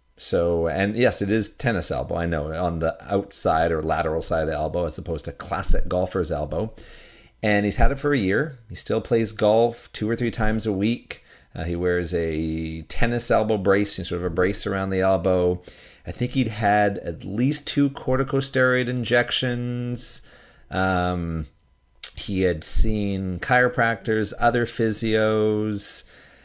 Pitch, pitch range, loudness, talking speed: 105 Hz, 90-120 Hz, -23 LUFS, 160 wpm